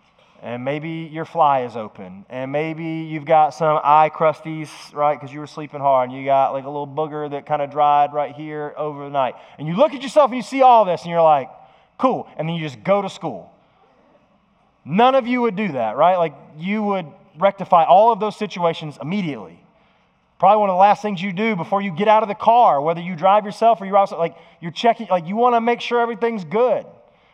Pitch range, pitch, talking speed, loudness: 150-210 Hz, 165 Hz, 230 wpm, -18 LUFS